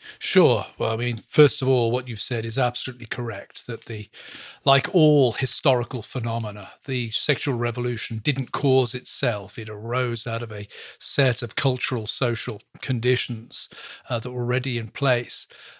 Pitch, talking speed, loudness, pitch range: 120 Hz, 155 wpm, -24 LUFS, 115-130 Hz